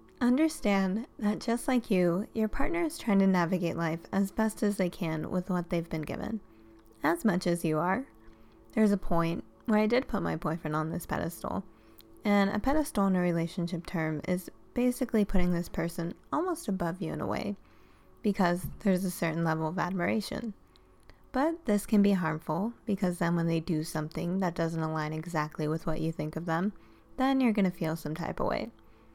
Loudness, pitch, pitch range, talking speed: -31 LUFS, 180 Hz, 160-210 Hz, 195 wpm